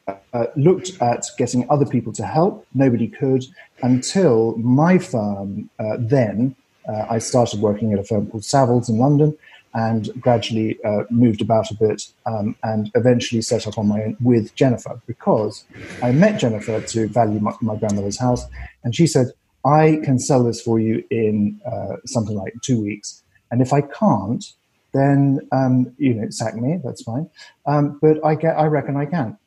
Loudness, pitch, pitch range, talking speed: -19 LUFS, 120 Hz, 110-135 Hz, 180 wpm